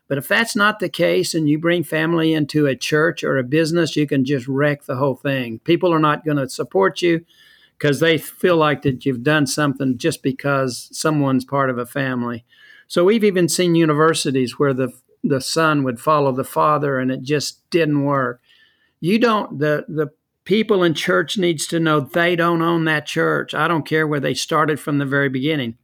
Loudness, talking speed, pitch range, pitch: -19 LUFS, 205 wpm, 140-170 Hz, 150 Hz